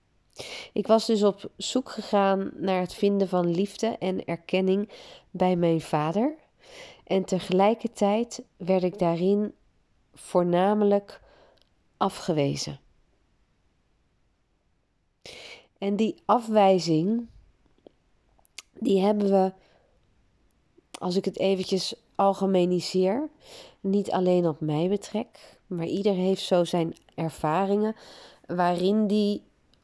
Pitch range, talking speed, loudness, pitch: 180-210 Hz, 95 wpm, -26 LUFS, 195 Hz